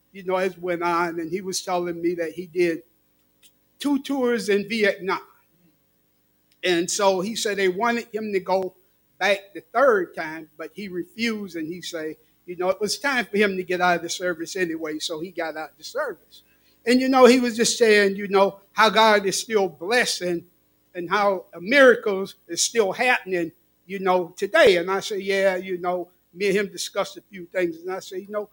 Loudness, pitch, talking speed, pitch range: -22 LUFS, 185 Hz, 205 wpm, 175-205 Hz